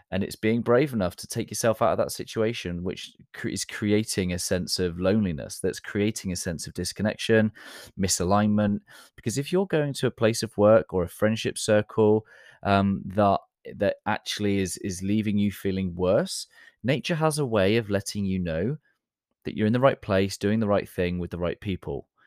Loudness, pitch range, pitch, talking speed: -26 LUFS, 95-115 Hz, 105 Hz, 190 wpm